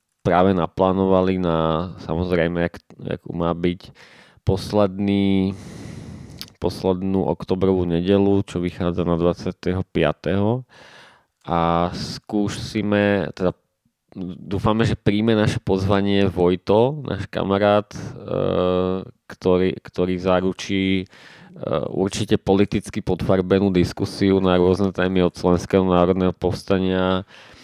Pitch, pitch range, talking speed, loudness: 95 Hz, 90-100 Hz, 90 wpm, -21 LUFS